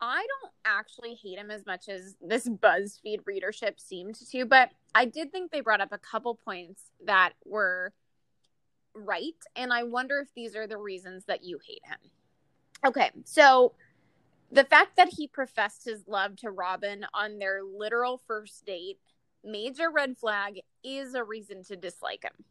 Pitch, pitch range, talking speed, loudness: 220 Hz, 200-270 Hz, 170 wpm, -27 LUFS